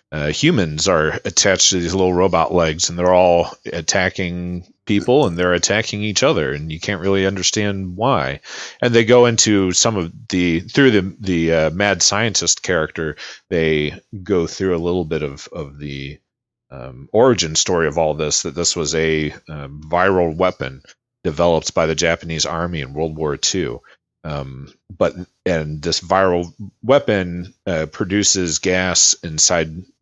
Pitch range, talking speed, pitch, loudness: 80-95 Hz, 160 wpm, 90 Hz, -17 LUFS